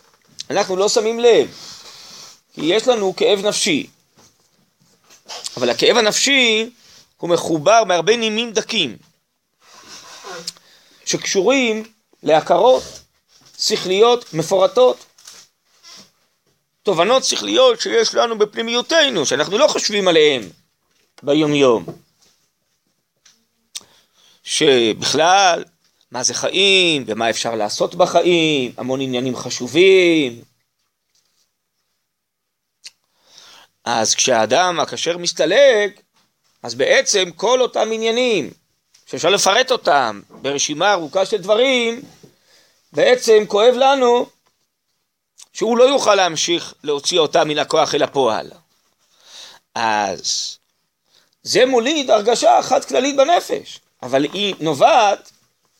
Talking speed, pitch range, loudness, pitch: 85 wpm, 170-260 Hz, -16 LUFS, 215 Hz